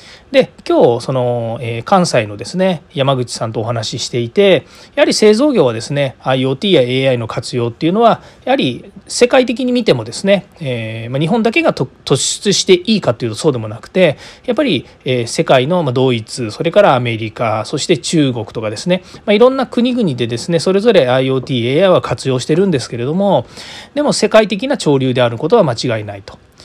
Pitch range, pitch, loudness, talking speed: 120-200 Hz, 140 Hz, -14 LUFS, 355 characters per minute